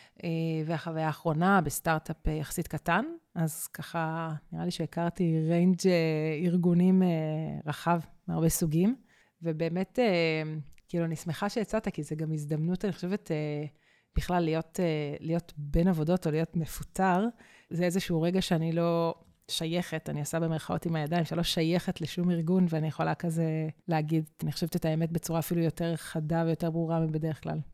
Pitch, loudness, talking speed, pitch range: 165 Hz, -30 LUFS, 145 wpm, 160-175 Hz